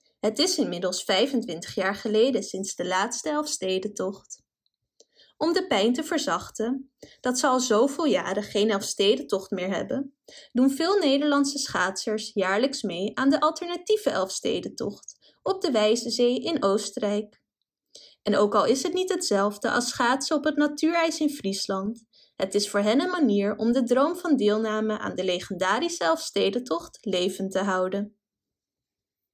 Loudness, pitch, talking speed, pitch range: -25 LUFS, 220 Hz, 145 wpm, 195-280 Hz